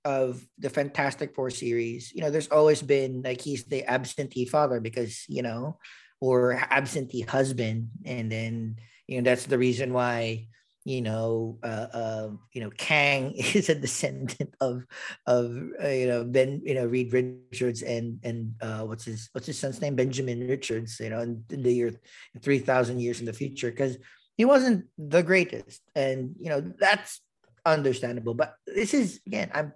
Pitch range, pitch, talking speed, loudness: 120-140 Hz, 125 Hz, 175 wpm, -27 LUFS